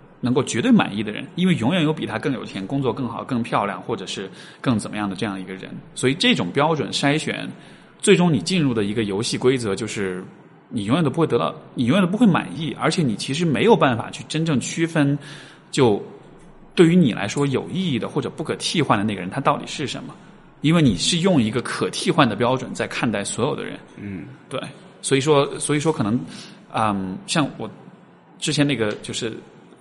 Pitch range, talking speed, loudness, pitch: 110-165 Hz, 315 characters per minute, -21 LUFS, 140 Hz